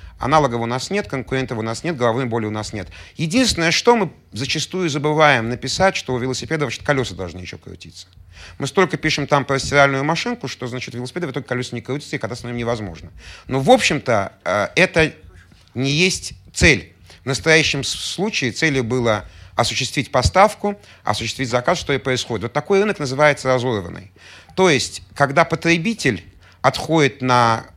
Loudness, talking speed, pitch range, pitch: -19 LUFS, 165 wpm, 105-155 Hz, 130 Hz